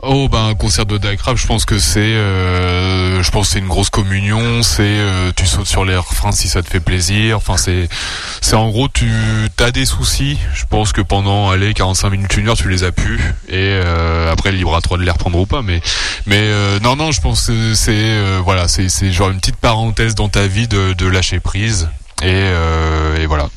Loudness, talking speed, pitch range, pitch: -14 LUFS, 230 wpm, 90-110 Hz, 100 Hz